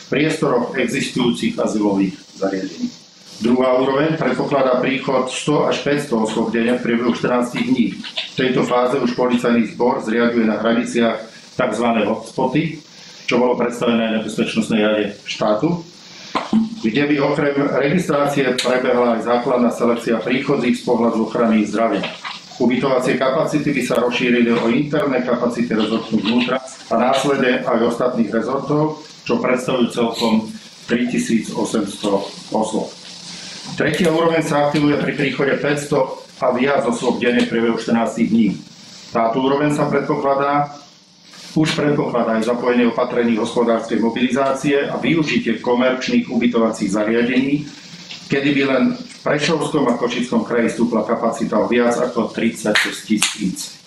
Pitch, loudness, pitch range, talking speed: 125 Hz, -18 LUFS, 115-145 Hz, 125 wpm